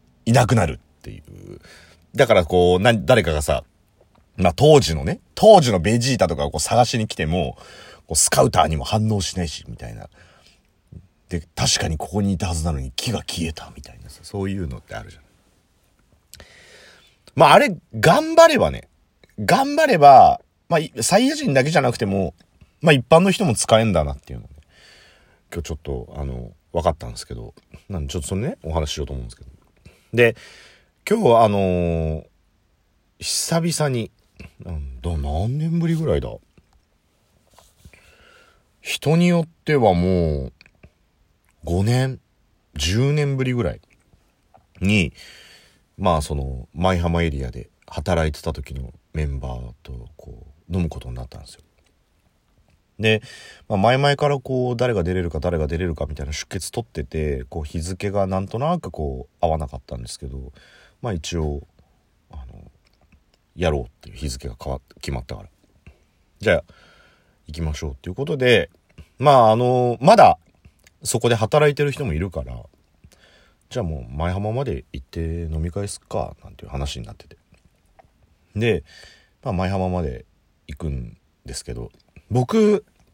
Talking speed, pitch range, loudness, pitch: 295 characters per minute, 75-110 Hz, -20 LUFS, 90 Hz